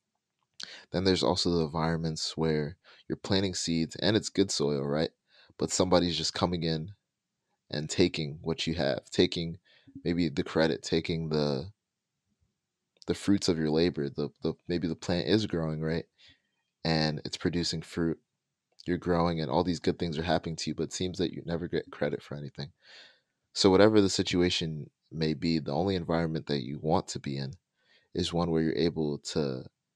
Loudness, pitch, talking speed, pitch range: -30 LUFS, 80 Hz, 180 wpm, 80-90 Hz